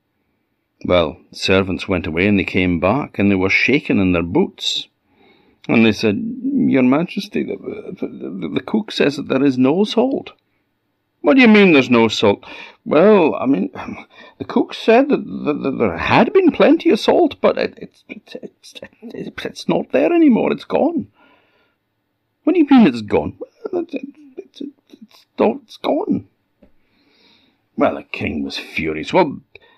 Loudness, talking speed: -16 LUFS, 170 wpm